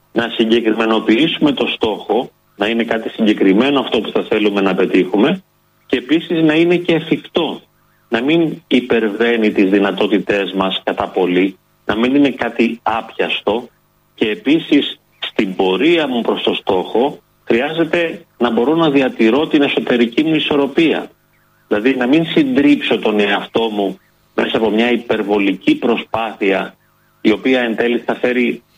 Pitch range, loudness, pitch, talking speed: 105-150 Hz, -15 LUFS, 115 Hz, 140 wpm